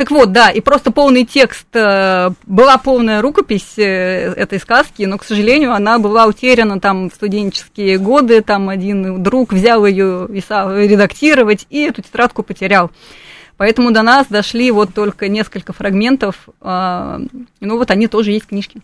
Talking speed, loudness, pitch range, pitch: 155 wpm, -12 LUFS, 195-245 Hz, 210 Hz